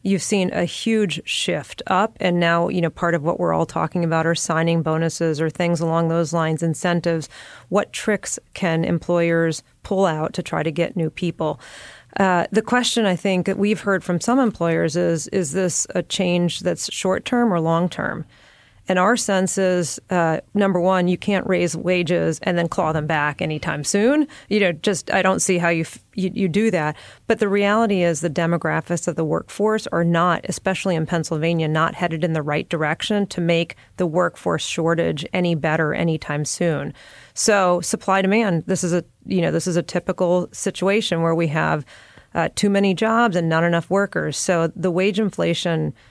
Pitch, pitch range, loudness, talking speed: 175 Hz, 165-190 Hz, -20 LUFS, 195 wpm